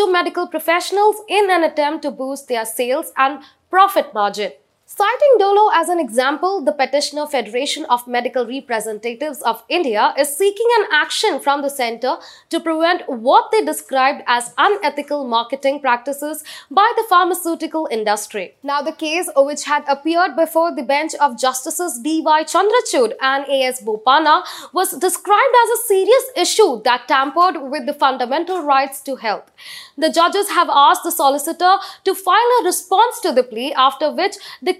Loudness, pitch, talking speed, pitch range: -17 LUFS, 300 Hz, 160 wpm, 270-360 Hz